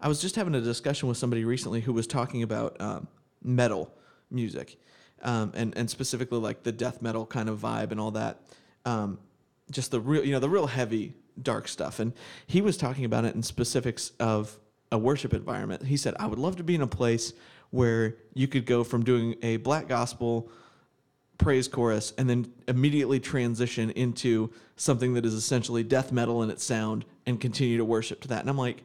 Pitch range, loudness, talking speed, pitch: 115-130 Hz, -29 LUFS, 200 wpm, 120 Hz